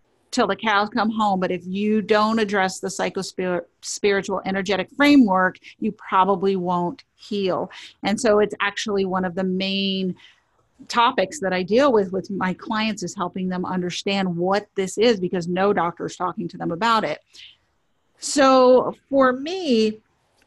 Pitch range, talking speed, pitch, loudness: 185-220 Hz, 160 wpm, 195 Hz, -21 LUFS